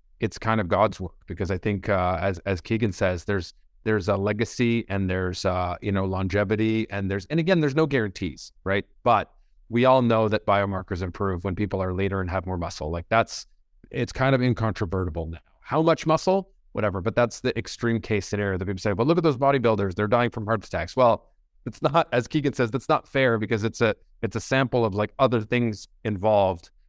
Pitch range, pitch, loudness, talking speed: 95-120 Hz, 105 Hz, -25 LUFS, 215 wpm